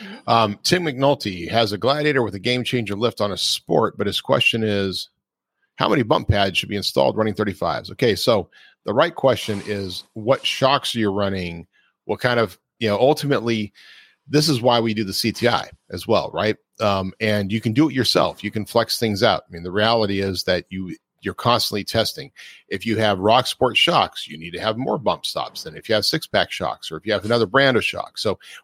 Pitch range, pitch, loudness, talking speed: 100-120 Hz, 110 Hz, -20 LUFS, 220 wpm